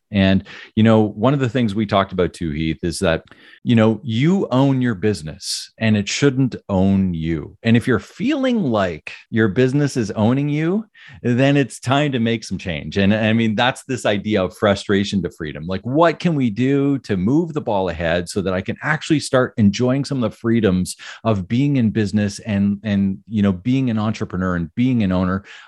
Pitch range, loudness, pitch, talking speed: 100-130 Hz, -19 LUFS, 110 Hz, 205 wpm